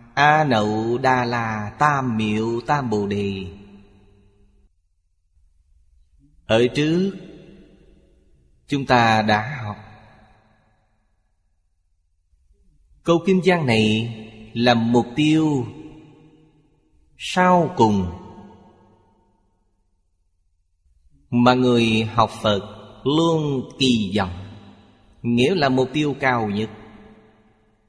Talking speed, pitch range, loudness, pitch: 80 wpm, 100-130 Hz, -20 LUFS, 110 Hz